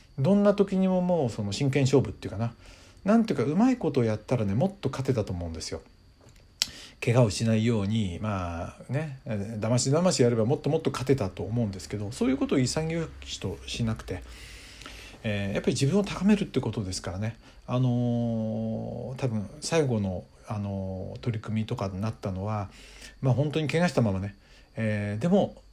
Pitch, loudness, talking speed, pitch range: 115 Hz, -28 LUFS, 375 characters per minute, 105-140 Hz